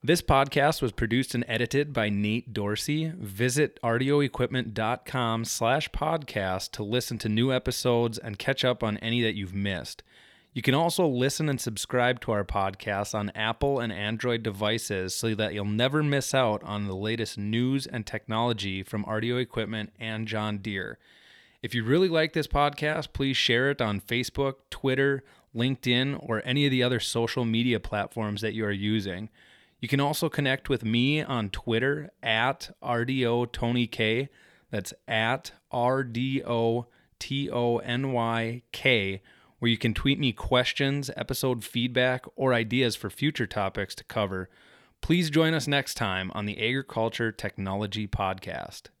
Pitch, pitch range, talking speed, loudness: 120 Hz, 110-135 Hz, 150 wpm, -27 LUFS